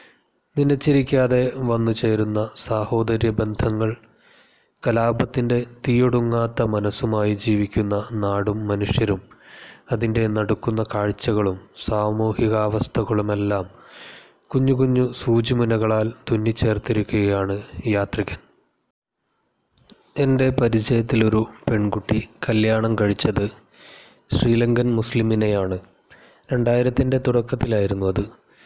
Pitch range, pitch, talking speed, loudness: 105-120 Hz, 110 Hz, 65 wpm, -21 LUFS